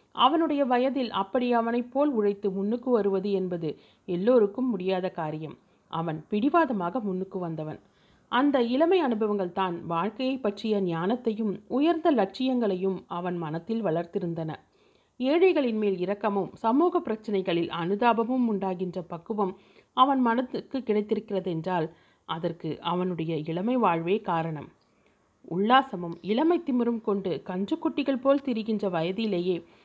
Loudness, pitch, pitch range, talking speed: -27 LUFS, 205 Hz, 180-245 Hz, 105 wpm